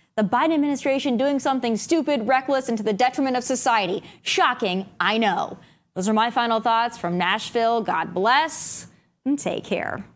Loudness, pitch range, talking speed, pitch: -22 LUFS, 215-270 Hz, 165 wpm, 240 Hz